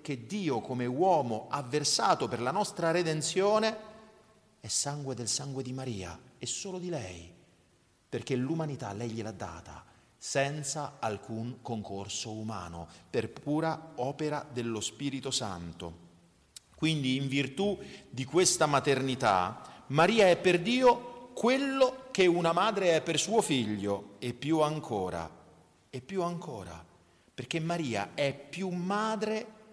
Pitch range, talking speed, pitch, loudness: 110-175 Hz, 130 wpm, 140 Hz, -31 LUFS